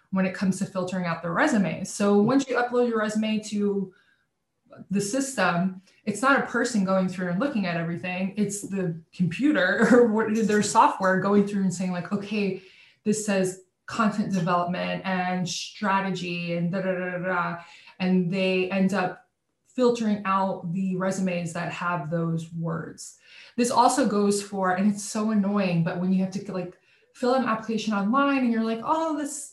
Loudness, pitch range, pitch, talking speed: -25 LUFS, 180-215 Hz, 195 Hz, 180 wpm